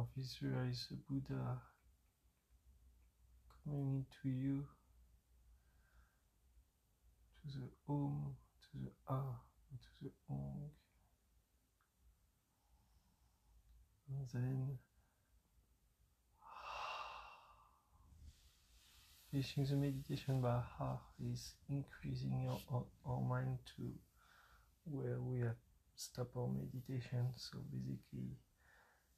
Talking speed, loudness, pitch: 75 wpm, -46 LUFS, 95 Hz